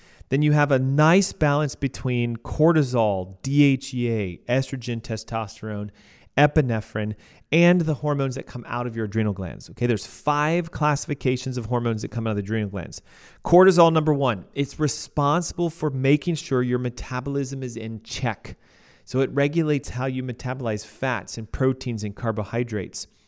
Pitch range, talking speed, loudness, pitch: 110-145 Hz, 150 wpm, -23 LUFS, 125 Hz